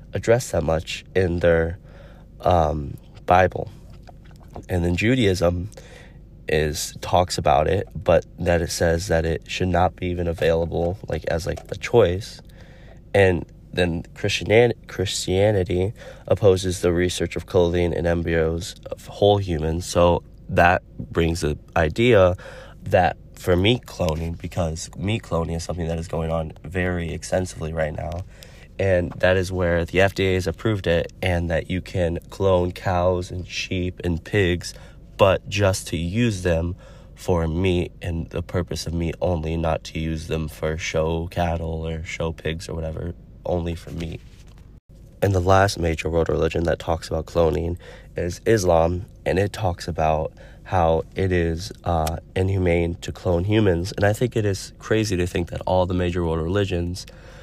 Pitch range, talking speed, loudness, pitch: 85-95 Hz, 160 wpm, -22 LUFS, 85 Hz